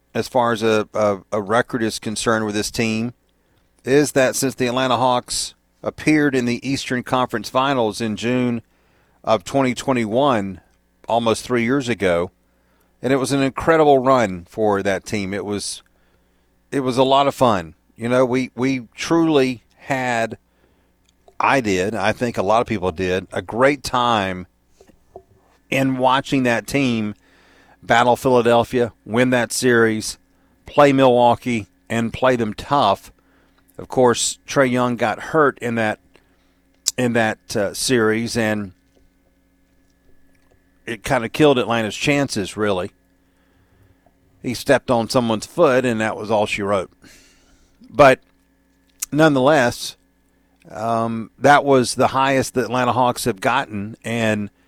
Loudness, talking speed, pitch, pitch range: -19 LUFS, 140 wpm, 115 Hz, 95-130 Hz